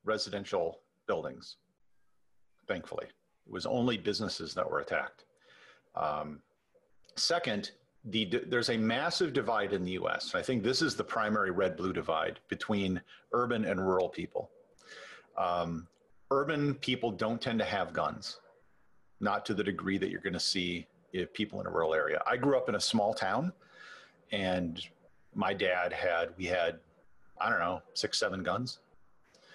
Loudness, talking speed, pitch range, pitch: -33 LUFS, 155 wpm, 90-120 Hz, 105 Hz